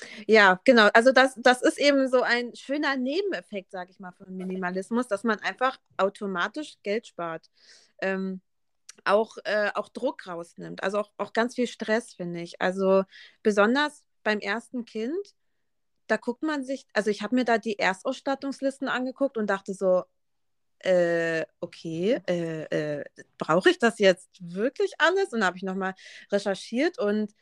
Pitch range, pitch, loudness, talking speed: 190-255 Hz, 215 Hz, -26 LUFS, 160 wpm